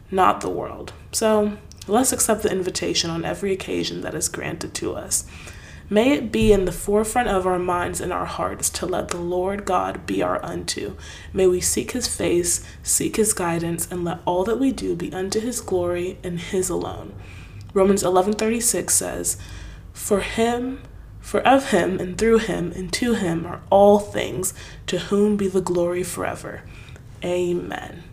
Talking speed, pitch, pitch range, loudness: 175 wpm, 185 Hz, 170-210 Hz, -22 LUFS